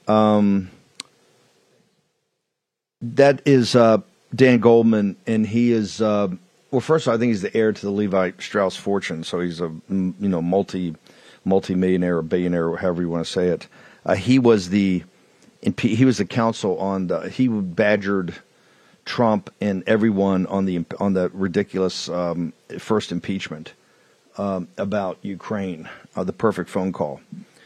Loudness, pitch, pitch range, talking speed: -21 LUFS, 100 Hz, 90-110 Hz, 150 wpm